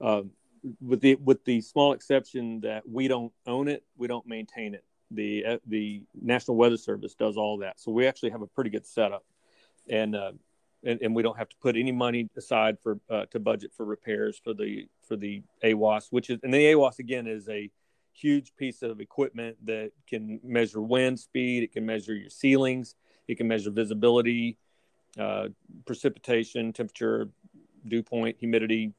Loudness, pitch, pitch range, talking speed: -28 LUFS, 115 Hz, 110-125 Hz, 180 wpm